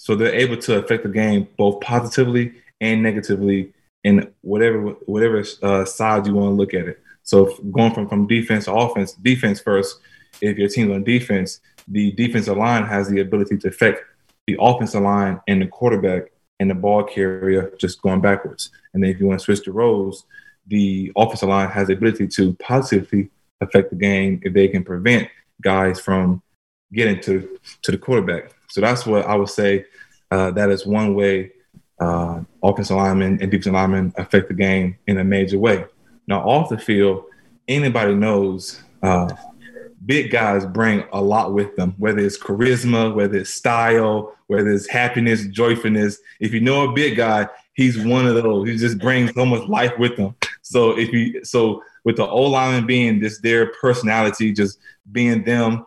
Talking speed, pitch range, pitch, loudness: 180 wpm, 95-115 Hz, 105 Hz, -18 LUFS